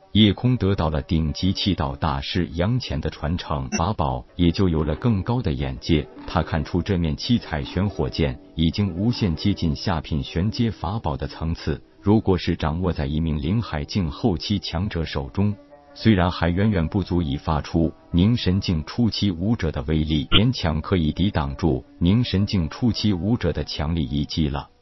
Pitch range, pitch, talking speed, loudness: 80-100 Hz, 85 Hz, 265 characters per minute, -23 LUFS